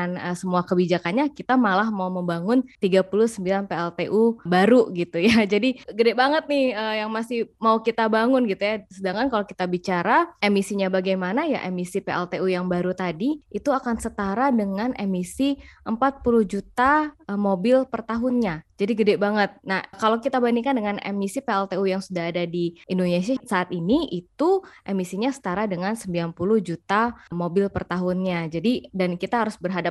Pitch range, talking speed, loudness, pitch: 180-235 Hz, 155 wpm, -23 LUFS, 200 Hz